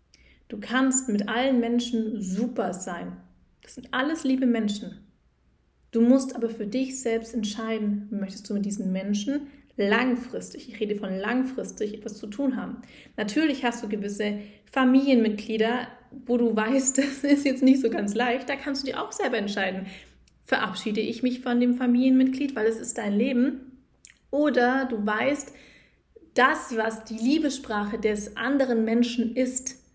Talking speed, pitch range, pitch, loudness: 155 wpm, 215-260 Hz, 235 Hz, -25 LUFS